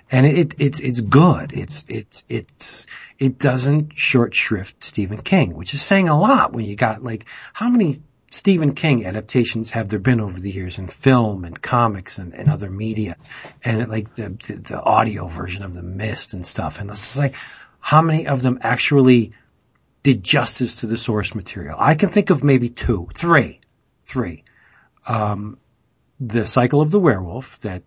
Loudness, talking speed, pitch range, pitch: -19 LUFS, 185 wpm, 105-140 Hz, 120 Hz